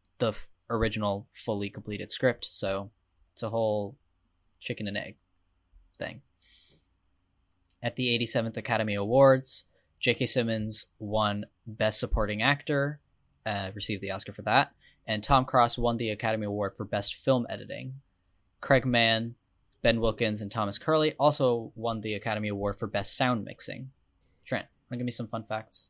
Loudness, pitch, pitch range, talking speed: -29 LUFS, 110 Hz, 100-120 Hz, 155 wpm